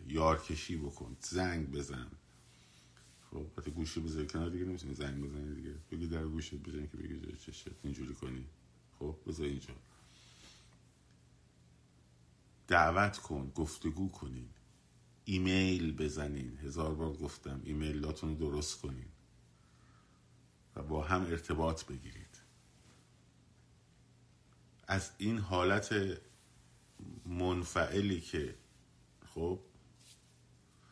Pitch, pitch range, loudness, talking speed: 75 Hz, 65-85 Hz, -38 LUFS, 95 wpm